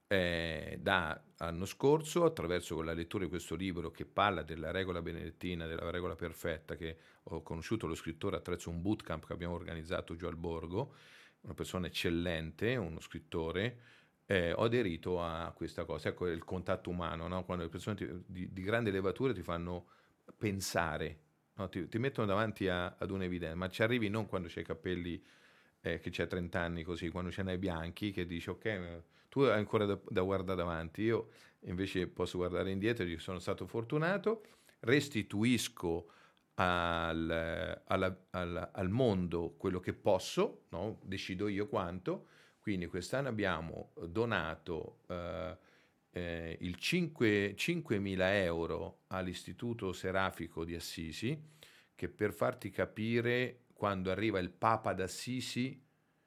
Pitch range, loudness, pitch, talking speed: 85-105 Hz, -37 LUFS, 90 Hz, 150 wpm